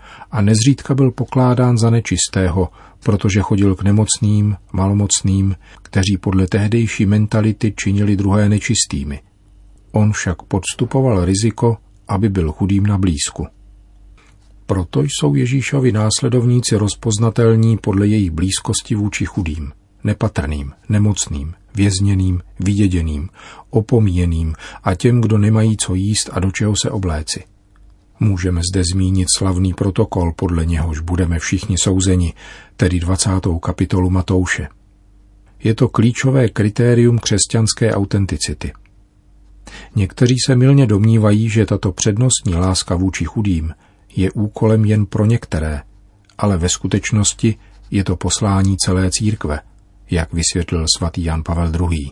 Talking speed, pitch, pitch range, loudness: 115 wpm, 100 Hz, 95-110 Hz, -16 LUFS